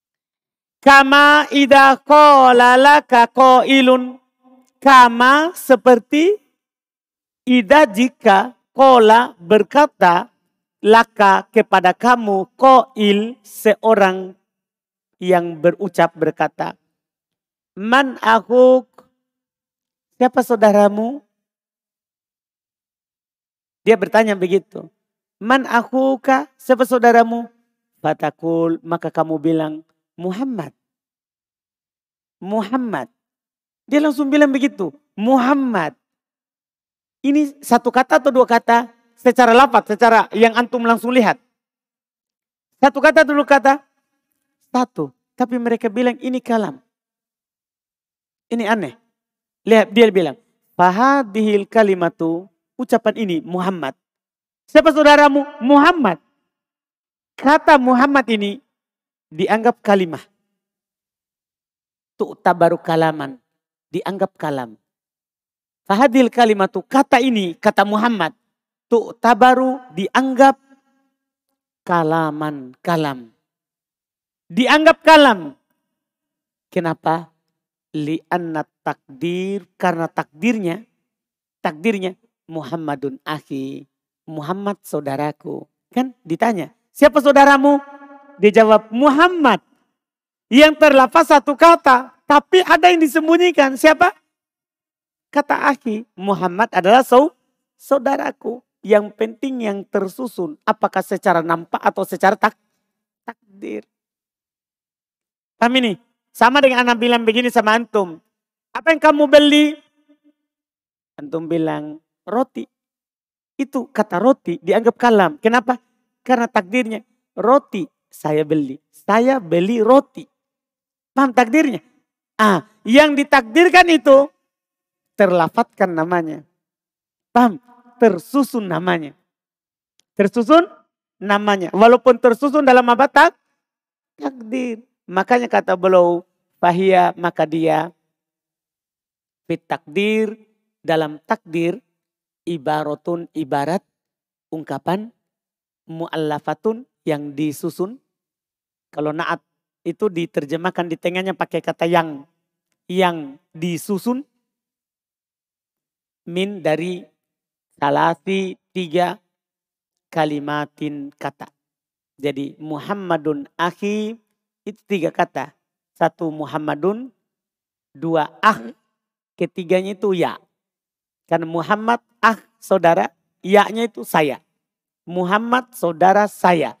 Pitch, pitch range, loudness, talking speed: 215 Hz, 175-255 Hz, -15 LUFS, 85 wpm